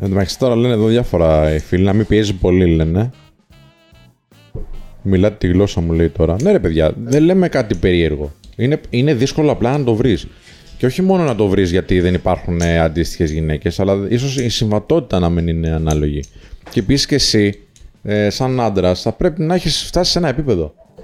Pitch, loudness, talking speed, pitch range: 100 Hz, -15 LUFS, 190 wpm, 85-125 Hz